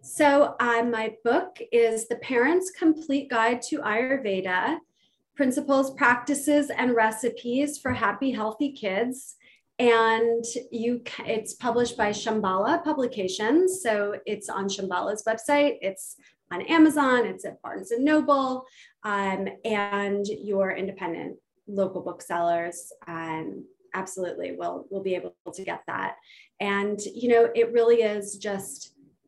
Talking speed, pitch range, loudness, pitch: 125 wpm, 200-270 Hz, -25 LUFS, 230 Hz